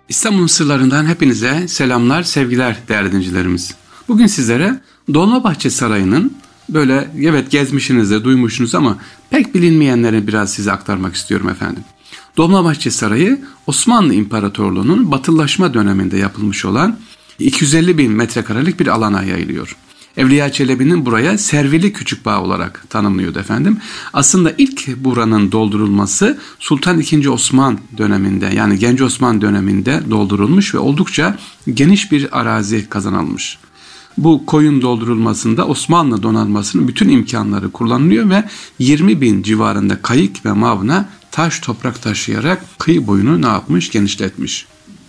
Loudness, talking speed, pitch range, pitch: -13 LUFS, 120 wpm, 105-160 Hz, 125 Hz